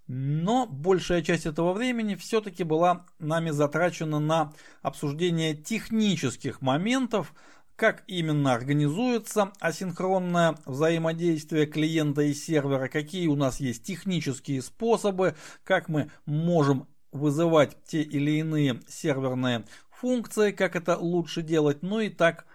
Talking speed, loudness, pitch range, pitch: 115 wpm, -27 LUFS, 150-185 Hz, 165 Hz